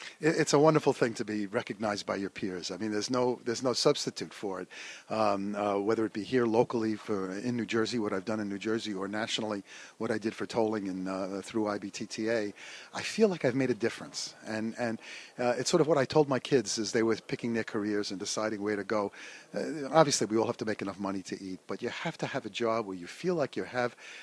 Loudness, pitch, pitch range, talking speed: -31 LUFS, 110 Hz, 105-125 Hz, 250 wpm